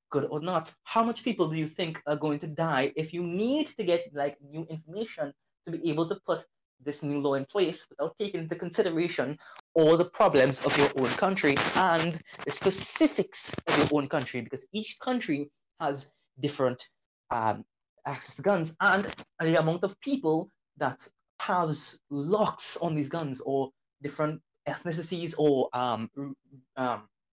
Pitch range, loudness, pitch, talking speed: 140-180 Hz, -29 LUFS, 155 Hz, 165 wpm